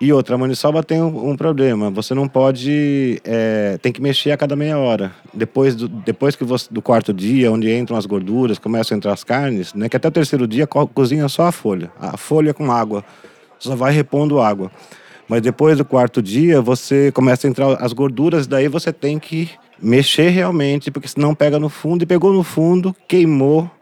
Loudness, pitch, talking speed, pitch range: -16 LUFS, 140 Hz, 200 wpm, 120-150 Hz